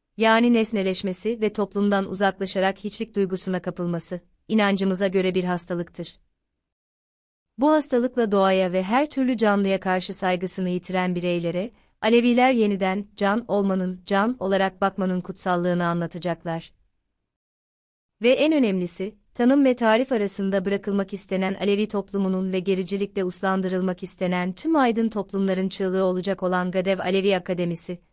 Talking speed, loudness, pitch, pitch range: 120 wpm, -23 LUFS, 190 Hz, 180-205 Hz